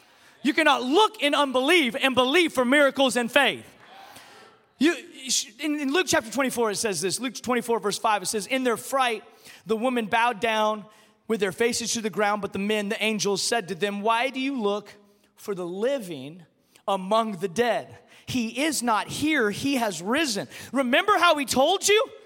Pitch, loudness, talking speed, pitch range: 235 Hz, -24 LUFS, 185 wpm, 210-275 Hz